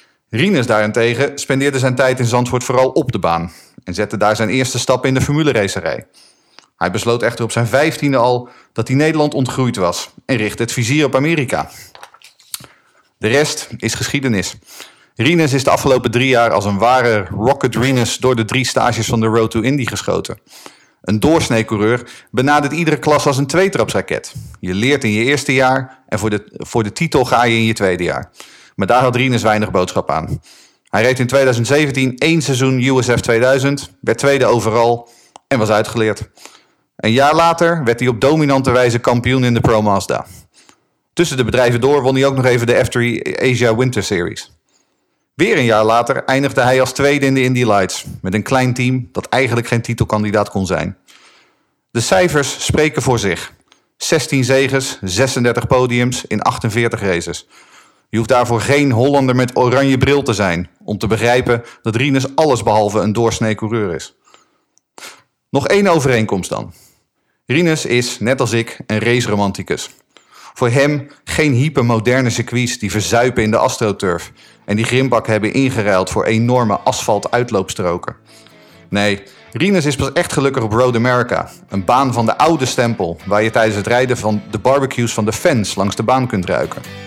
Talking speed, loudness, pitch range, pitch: 175 wpm, -15 LUFS, 110-135 Hz, 120 Hz